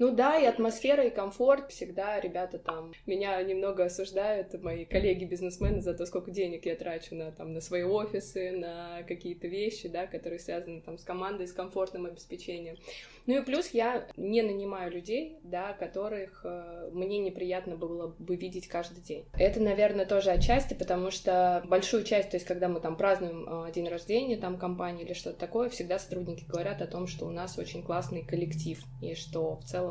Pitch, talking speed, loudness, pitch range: 180 Hz, 180 wpm, -32 LUFS, 170-200 Hz